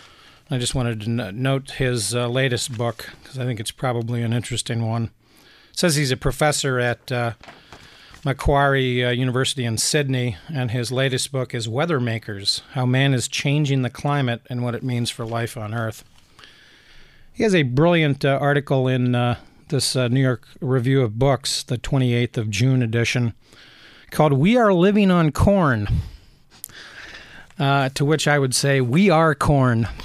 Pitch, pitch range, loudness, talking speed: 130 Hz, 120-140 Hz, -21 LUFS, 170 wpm